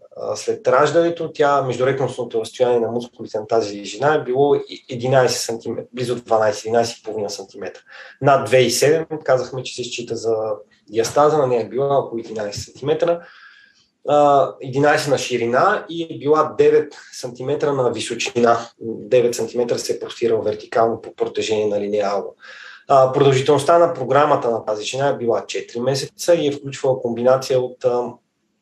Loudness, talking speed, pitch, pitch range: -19 LUFS, 145 wpm, 135 Hz, 120-160 Hz